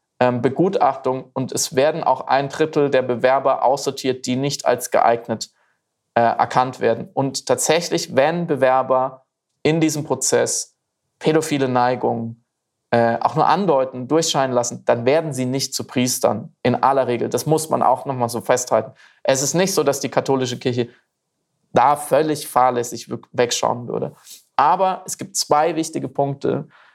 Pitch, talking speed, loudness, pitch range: 135 Hz, 150 wpm, -19 LUFS, 125-150 Hz